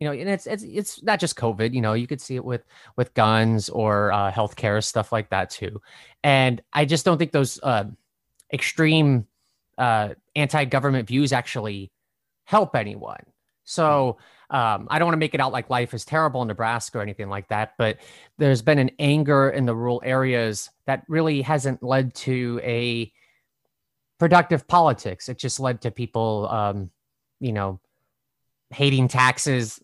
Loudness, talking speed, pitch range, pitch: -22 LUFS, 170 wpm, 110-145 Hz, 125 Hz